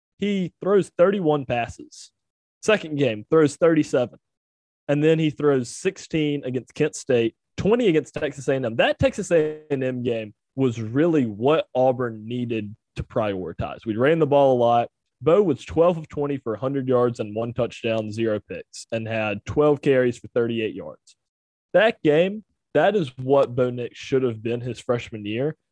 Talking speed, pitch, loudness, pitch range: 165 wpm, 135 Hz, -23 LUFS, 115-155 Hz